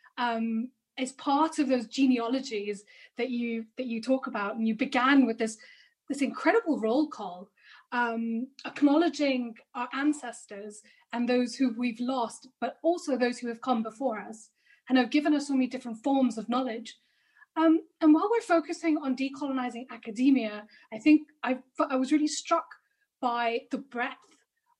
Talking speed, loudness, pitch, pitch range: 160 wpm, -28 LUFS, 255 Hz, 235-295 Hz